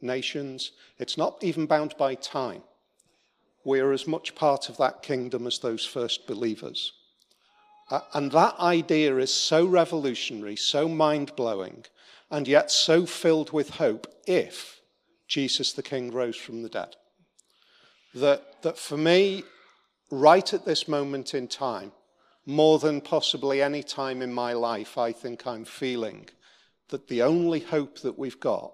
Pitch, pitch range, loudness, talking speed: 145 Hz, 130-160 Hz, -26 LUFS, 150 wpm